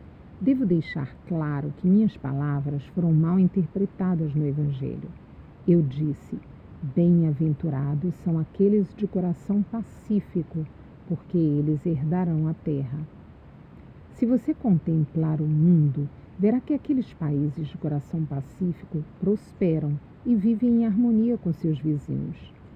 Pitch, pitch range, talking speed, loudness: 165 Hz, 150-195 Hz, 115 wpm, -25 LUFS